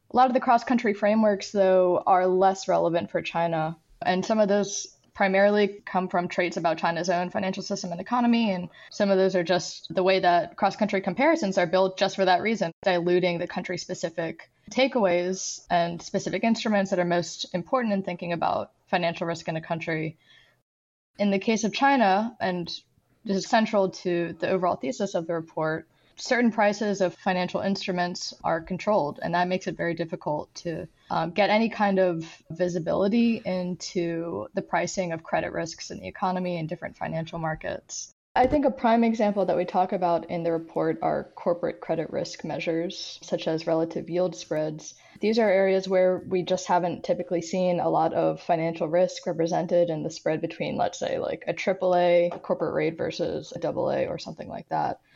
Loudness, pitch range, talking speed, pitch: -26 LUFS, 170-200 Hz, 185 wpm, 180 Hz